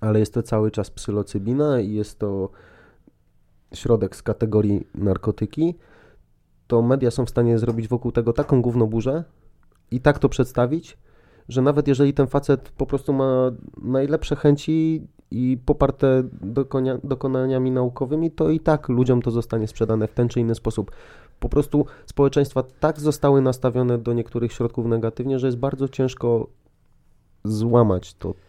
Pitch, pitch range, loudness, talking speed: 125 Hz, 115-140 Hz, -22 LUFS, 145 wpm